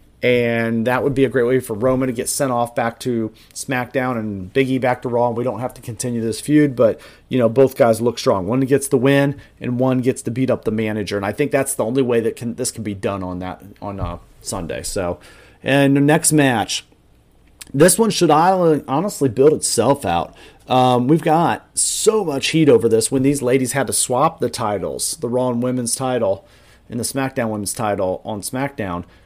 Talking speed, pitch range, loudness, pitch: 215 wpm, 110-135 Hz, -18 LUFS, 125 Hz